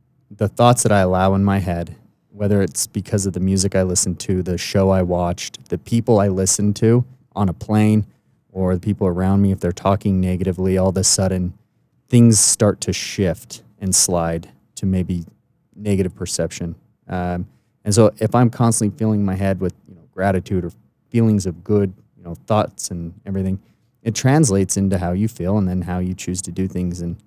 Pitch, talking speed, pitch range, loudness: 95 Hz, 195 wpm, 90-105 Hz, -19 LUFS